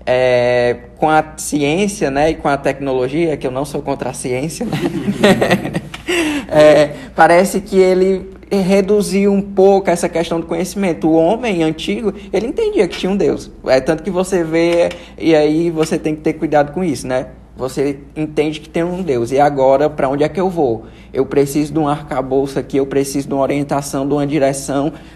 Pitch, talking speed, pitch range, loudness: 155 Hz, 190 wpm, 140-180 Hz, -15 LUFS